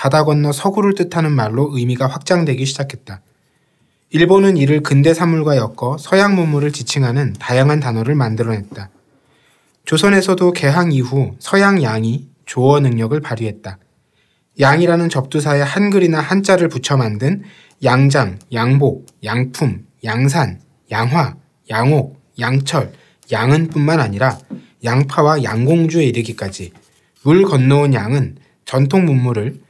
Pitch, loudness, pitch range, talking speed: 140 Hz, -15 LUFS, 125-160 Hz, 285 characters per minute